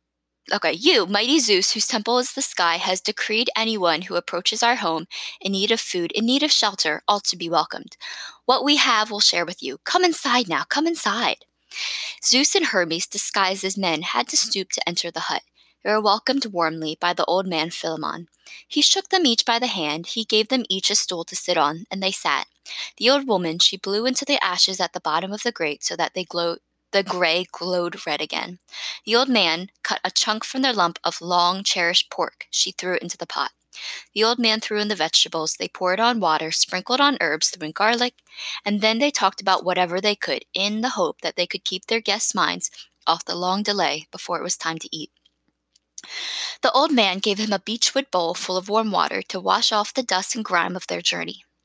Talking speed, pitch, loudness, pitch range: 220 wpm, 195 Hz, -20 LUFS, 175-225 Hz